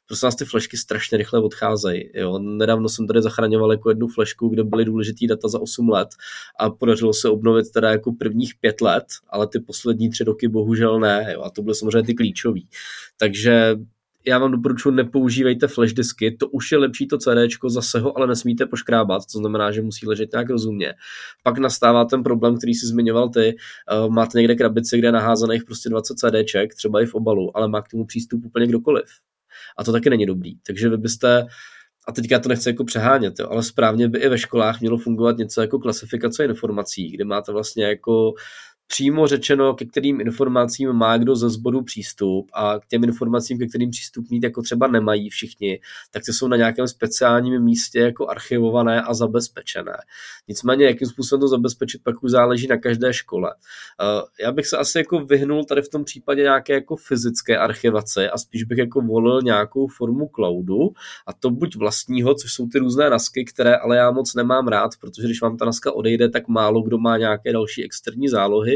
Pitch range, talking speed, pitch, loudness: 110-125 Hz, 195 wpm, 120 Hz, -20 LUFS